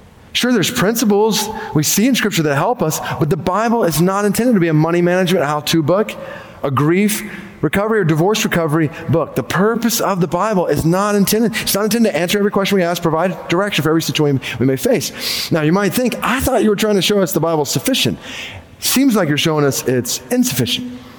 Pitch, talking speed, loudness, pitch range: 180 Hz, 225 wpm, -15 LUFS, 155-210 Hz